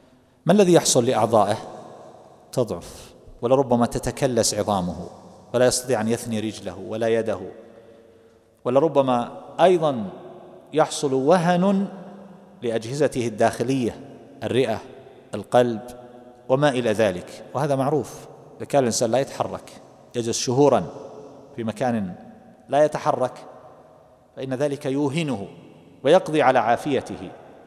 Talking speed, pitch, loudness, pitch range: 100 wpm, 125 Hz, -22 LUFS, 115-145 Hz